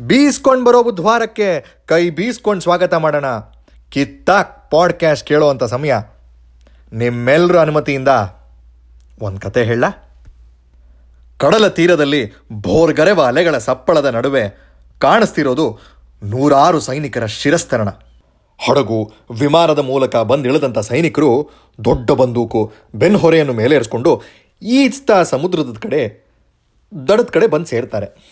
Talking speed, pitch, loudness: 90 wpm, 130 Hz, -14 LUFS